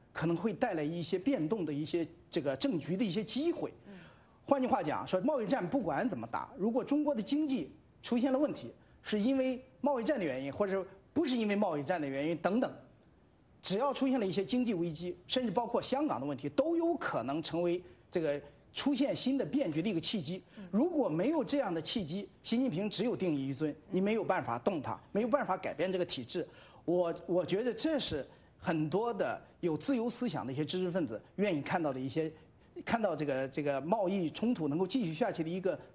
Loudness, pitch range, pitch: -34 LUFS, 165-260 Hz, 195 Hz